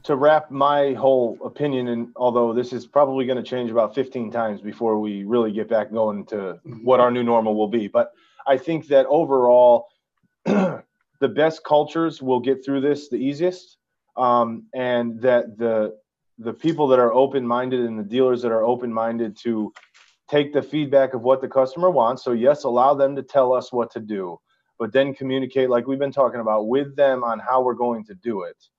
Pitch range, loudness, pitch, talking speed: 115-140 Hz, -21 LUFS, 125 Hz, 195 wpm